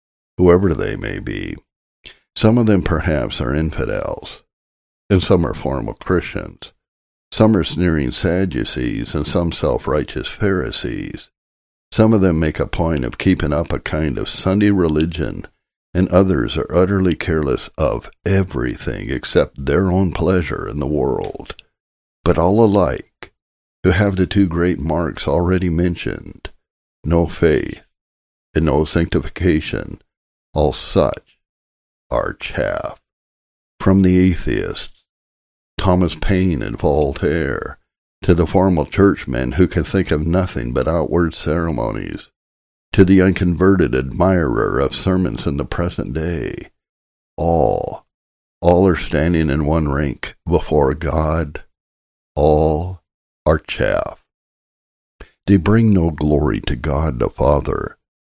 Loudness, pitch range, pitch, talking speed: -18 LUFS, 70-95 Hz, 85 Hz, 125 wpm